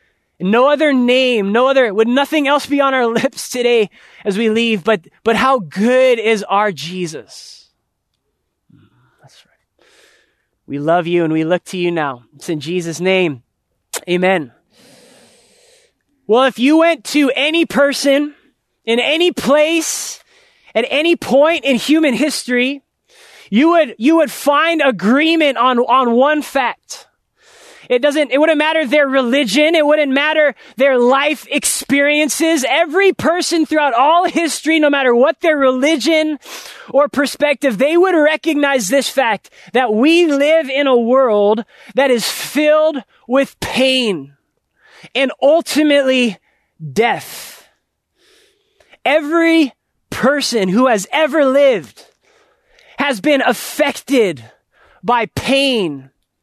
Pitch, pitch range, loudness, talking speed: 275 Hz, 235-305 Hz, -14 LUFS, 130 wpm